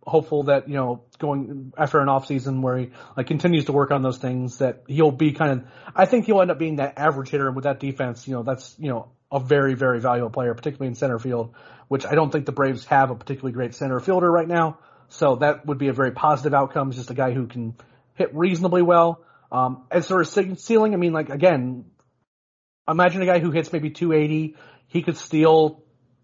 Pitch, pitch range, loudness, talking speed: 140 Hz, 130-160 Hz, -22 LUFS, 230 wpm